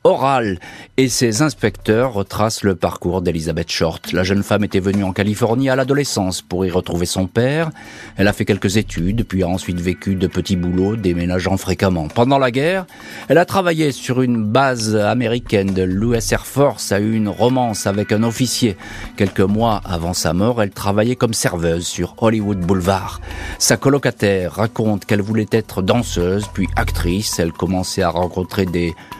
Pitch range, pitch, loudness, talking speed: 90-115 Hz, 100 Hz, -18 LUFS, 175 wpm